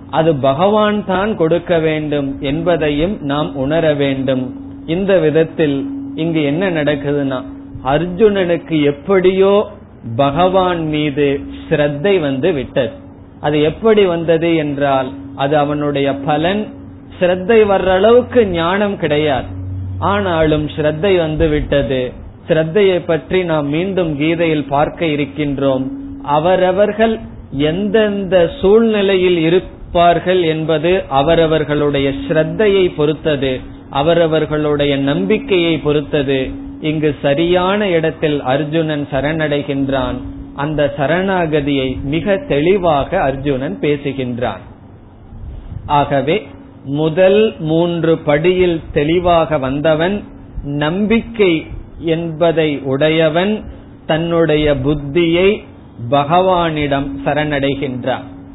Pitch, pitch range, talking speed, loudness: 155 Hz, 140-175 Hz, 80 wpm, -15 LUFS